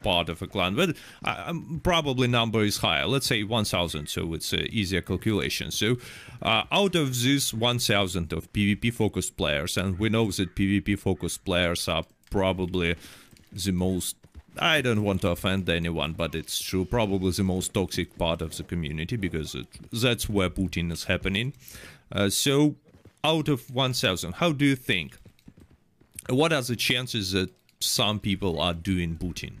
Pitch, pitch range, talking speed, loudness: 100 Hz, 85-120 Hz, 170 wpm, -26 LUFS